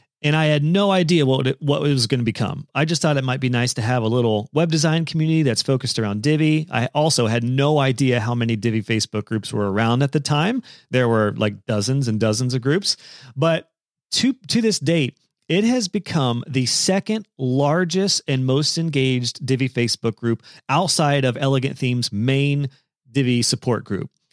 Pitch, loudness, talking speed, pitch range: 135 Hz, -20 LUFS, 190 wpm, 120-155 Hz